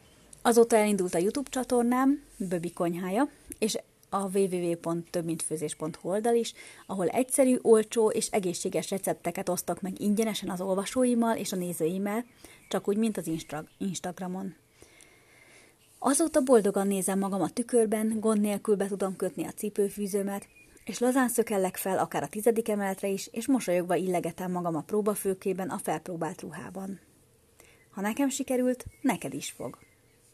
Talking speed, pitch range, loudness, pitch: 135 wpm, 180-225 Hz, -29 LUFS, 200 Hz